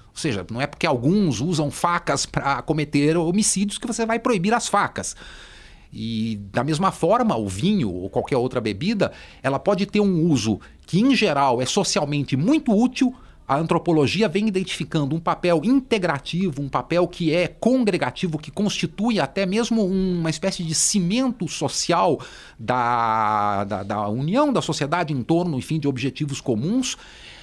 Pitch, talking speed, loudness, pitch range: 170 Hz, 160 wpm, -22 LUFS, 145-200 Hz